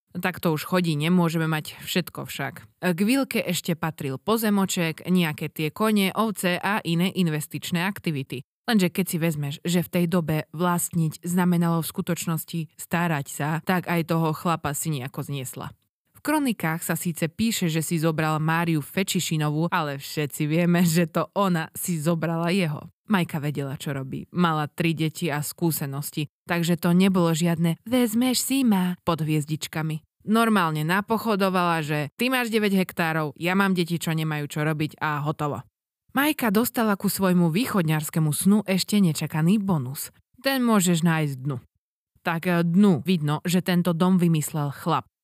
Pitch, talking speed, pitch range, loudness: 170 Hz, 155 wpm, 155-185 Hz, -24 LUFS